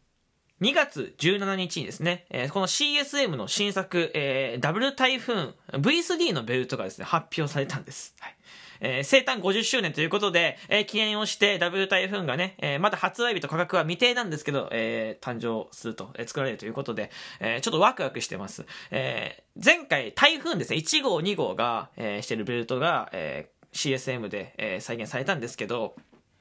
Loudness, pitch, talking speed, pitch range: -26 LUFS, 175 Hz, 375 characters per minute, 135-210 Hz